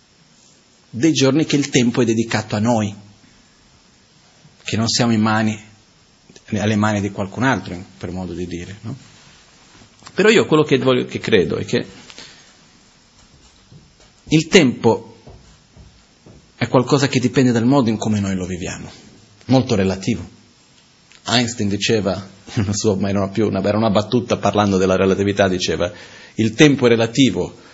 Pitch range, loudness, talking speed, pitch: 100-125 Hz, -17 LUFS, 145 wpm, 110 Hz